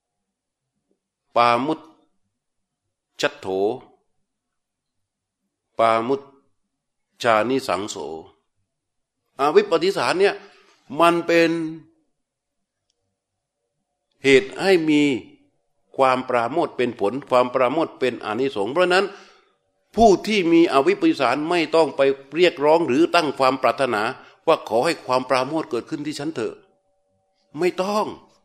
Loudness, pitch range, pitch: -20 LUFS, 125-180 Hz, 145 Hz